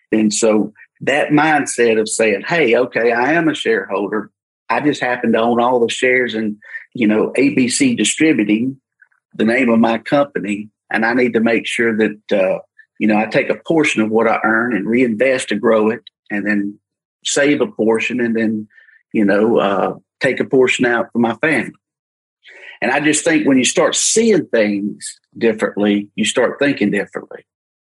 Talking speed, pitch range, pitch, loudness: 180 wpm, 110-140 Hz, 115 Hz, -16 LUFS